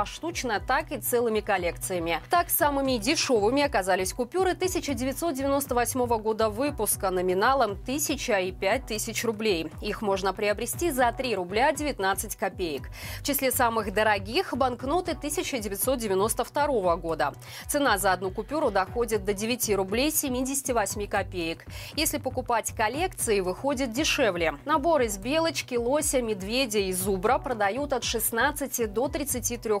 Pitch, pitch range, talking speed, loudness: 240 Hz, 205-285 Hz, 120 wpm, -26 LUFS